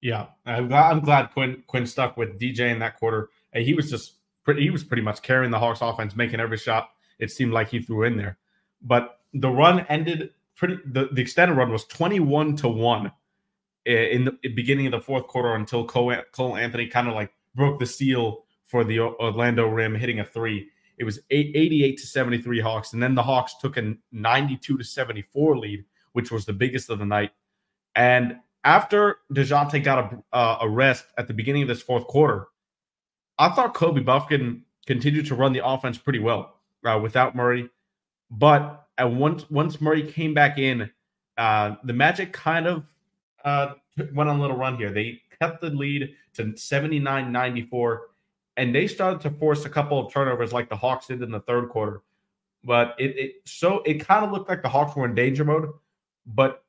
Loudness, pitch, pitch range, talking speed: -23 LUFS, 130 Hz, 115-145 Hz, 195 wpm